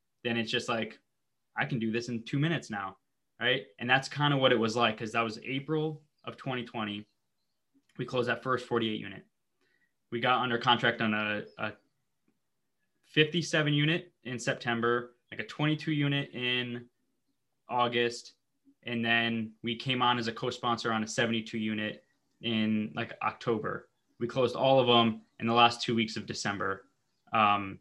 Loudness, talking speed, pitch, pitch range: -30 LUFS, 170 wpm, 120 Hz, 115-130 Hz